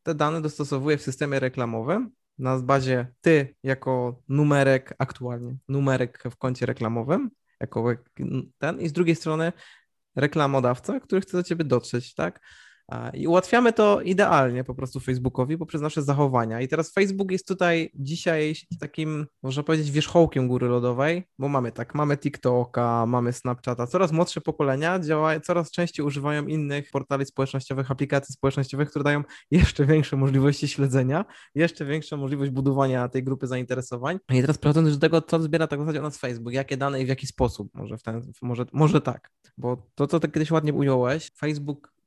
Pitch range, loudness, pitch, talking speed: 130-160 Hz, -25 LUFS, 140 Hz, 165 wpm